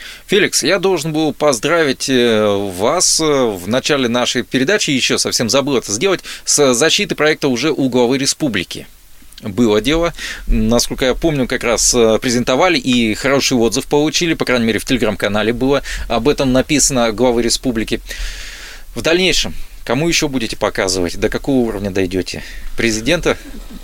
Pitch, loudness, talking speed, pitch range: 130 Hz, -15 LUFS, 140 wpm, 115-145 Hz